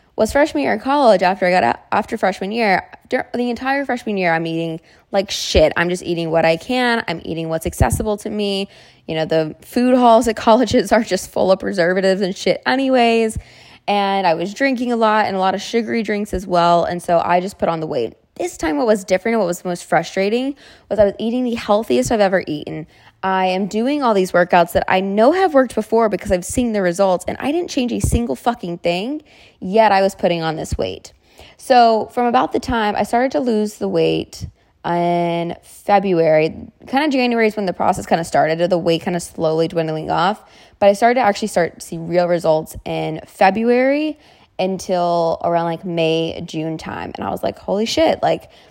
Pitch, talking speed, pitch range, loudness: 195 Hz, 215 wpm, 170-230 Hz, -17 LUFS